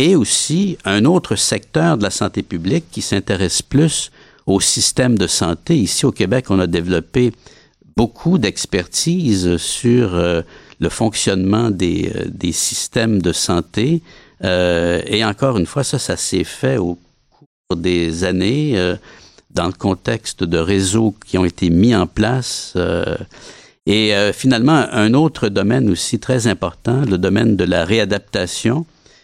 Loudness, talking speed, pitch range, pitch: -16 LUFS, 140 wpm, 90-120 Hz, 100 Hz